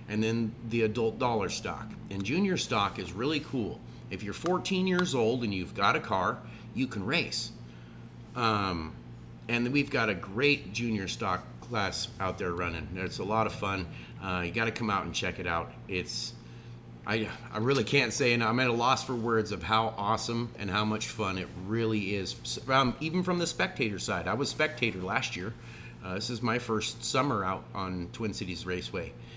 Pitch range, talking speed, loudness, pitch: 90-120 Hz, 200 wpm, -31 LUFS, 110 Hz